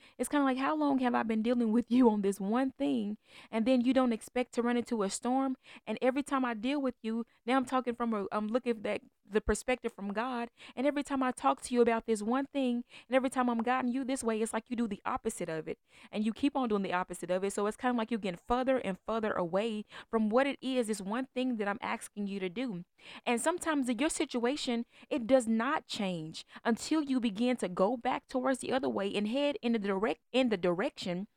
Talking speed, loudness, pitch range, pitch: 255 wpm, -32 LUFS, 215-260 Hz, 240 Hz